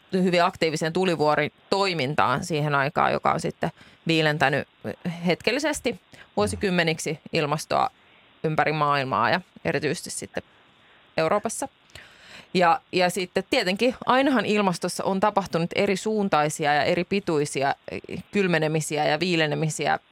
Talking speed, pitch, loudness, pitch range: 105 wpm, 175 Hz, -24 LUFS, 155-200 Hz